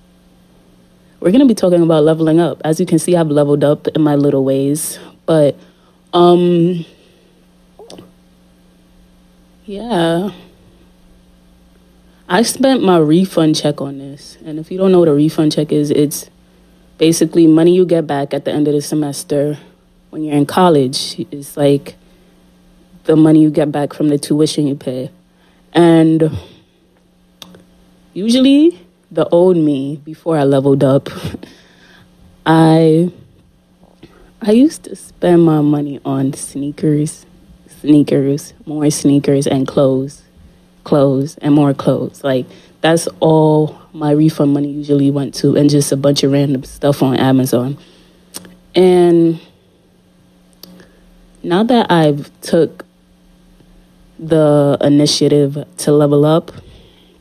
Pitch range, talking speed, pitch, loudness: 125-160 Hz, 130 wpm, 145 Hz, -13 LUFS